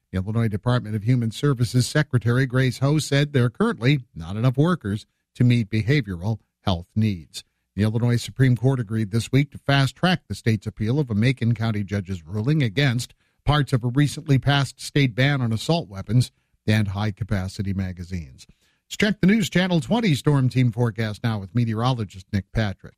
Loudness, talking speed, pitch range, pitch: -23 LUFS, 180 wpm, 105-140 Hz, 120 Hz